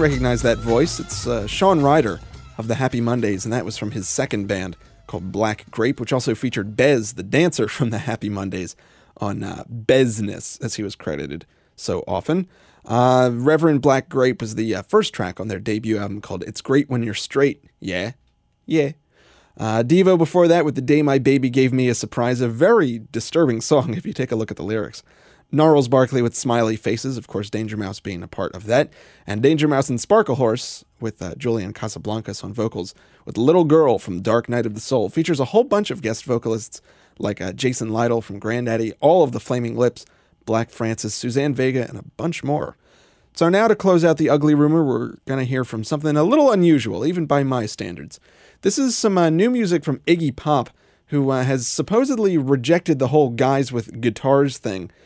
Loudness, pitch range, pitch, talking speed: -20 LUFS, 110-150 Hz, 125 Hz, 205 wpm